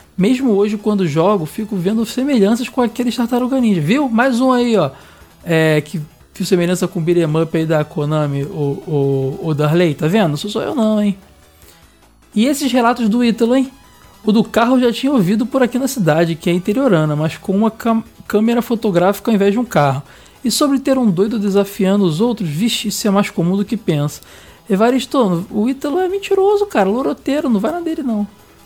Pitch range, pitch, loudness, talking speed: 175-240 Hz, 210 Hz, -16 LUFS, 200 wpm